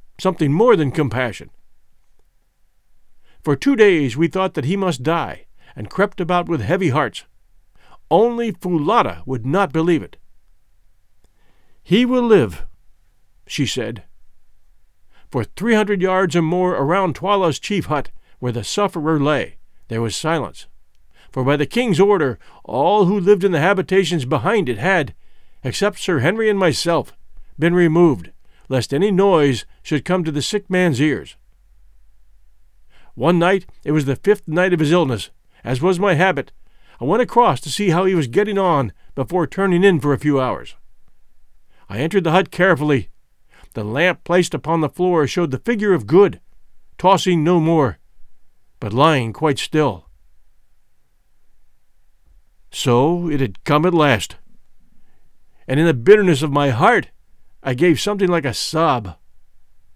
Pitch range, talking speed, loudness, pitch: 125-185 Hz, 150 wpm, -17 LUFS, 160 Hz